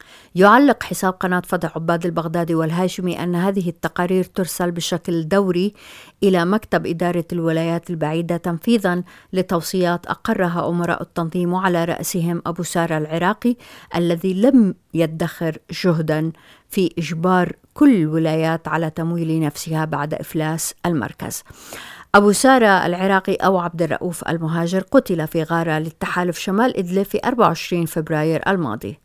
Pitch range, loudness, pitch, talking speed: 165-190 Hz, -19 LUFS, 175 Hz, 120 wpm